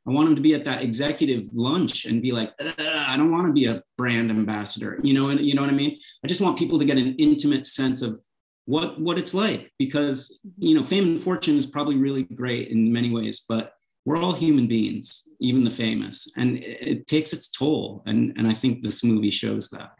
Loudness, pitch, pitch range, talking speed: -23 LUFS, 135 Hz, 115-165 Hz, 230 wpm